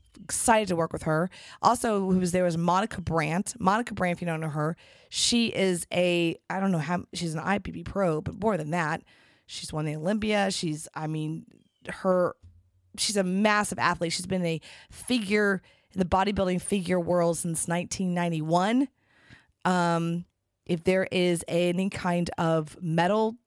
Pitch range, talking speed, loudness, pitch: 165-195 Hz, 165 wpm, -27 LUFS, 180 Hz